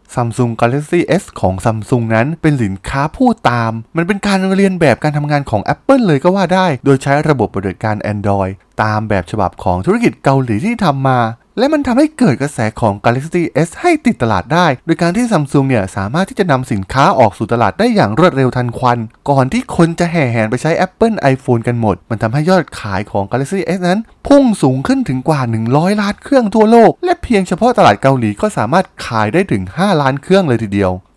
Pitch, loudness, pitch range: 140 Hz, -13 LUFS, 115-185 Hz